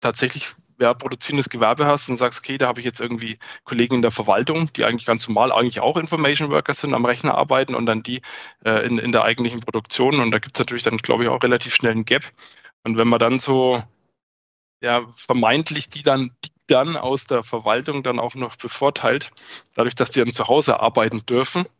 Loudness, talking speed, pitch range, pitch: -20 LUFS, 215 wpm, 115-135 Hz, 125 Hz